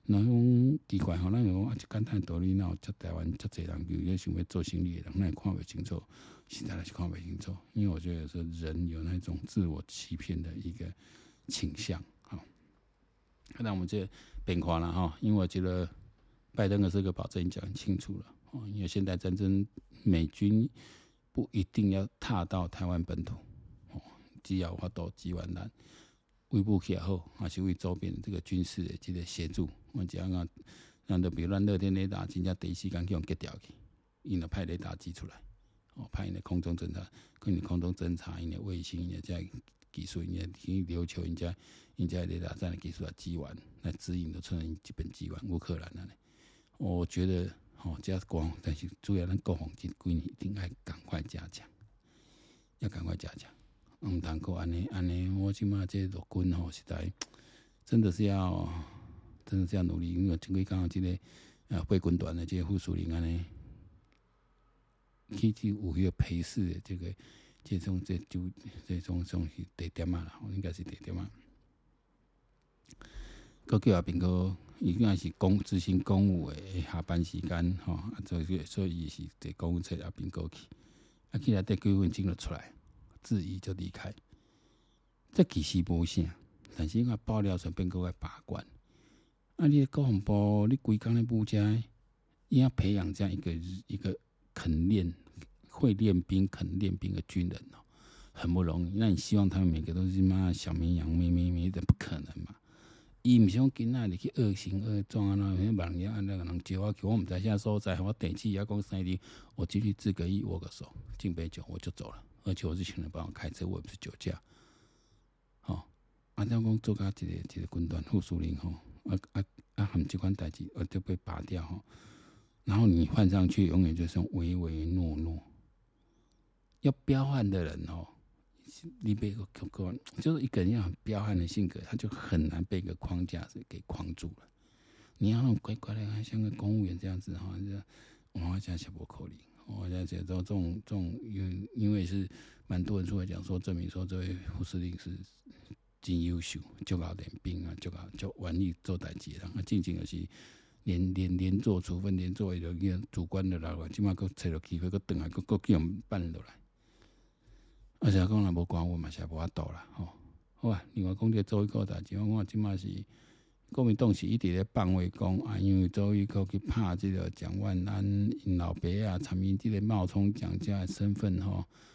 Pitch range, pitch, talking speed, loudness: 85-100 Hz, 95 Hz, 275 characters per minute, -34 LUFS